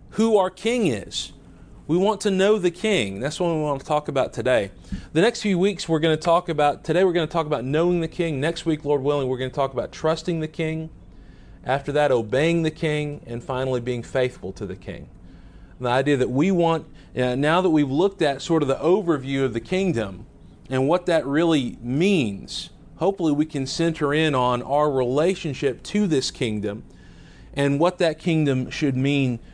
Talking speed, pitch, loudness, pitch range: 205 wpm, 150 Hz, -22 LUFS, 125-170 Hz